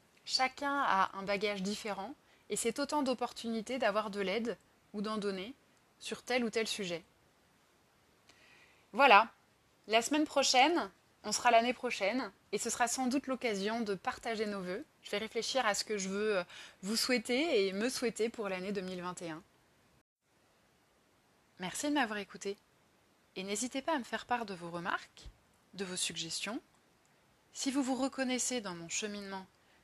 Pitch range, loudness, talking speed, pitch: 195-250 Hz, -34 LUFS, 155 wpm, 220 Hz